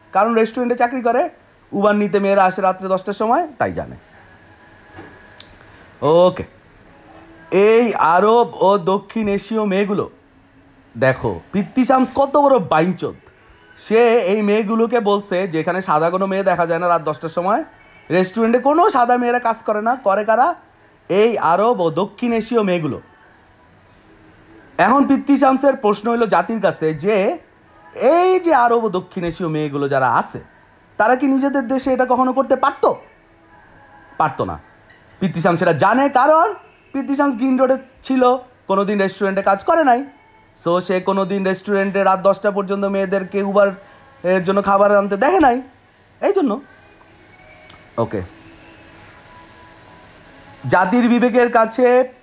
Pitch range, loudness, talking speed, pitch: 180-245 Hz, -17 LUFS, 130 wpm, 205 Hz